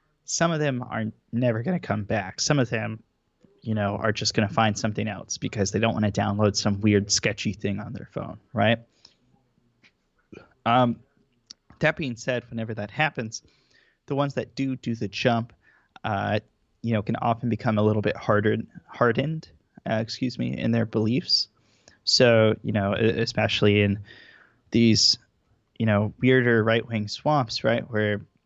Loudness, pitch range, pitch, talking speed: -24 LUFS, 105-125 Hz, 110 Hz, 170 wpm